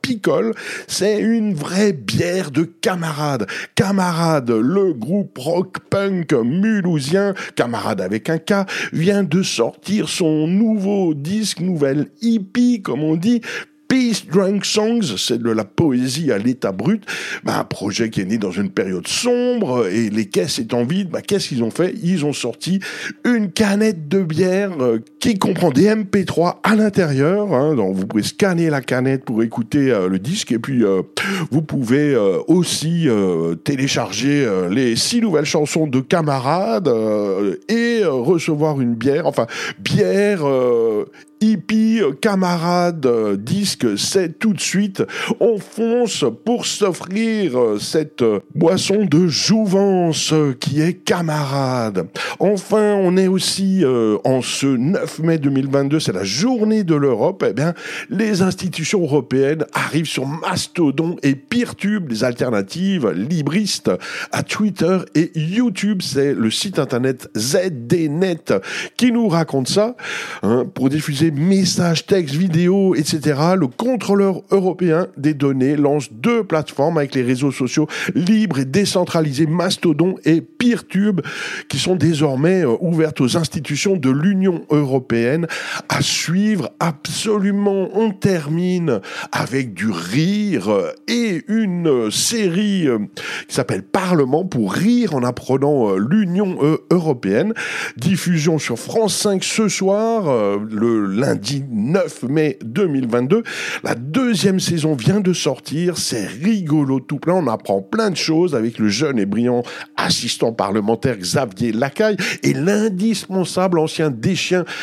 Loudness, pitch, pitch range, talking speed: -18 LUFS, 170 Hz, 140-200 Hz, 140 wpm